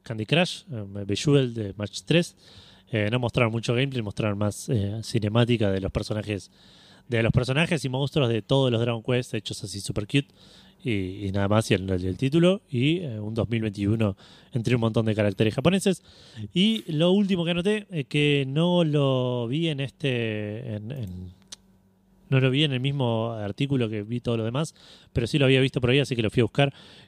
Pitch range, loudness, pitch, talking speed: 105-140 Hz, -25 LUFS, 120 Hz, 205 wpm